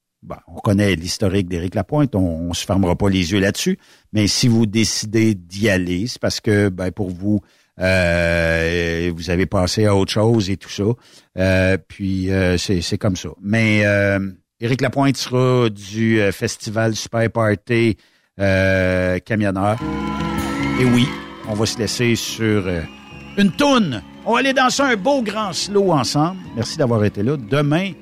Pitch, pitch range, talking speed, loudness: 105 Hz, 95-120 Hz, 165 wpm, -18 LUFS